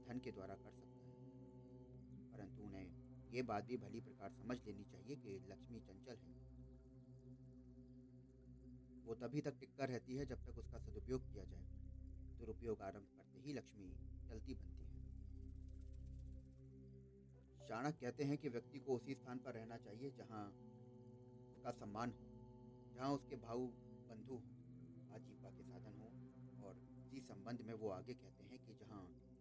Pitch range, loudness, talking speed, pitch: 95-125 Hz, -53 LUFS, 150 wpm, 120 Hz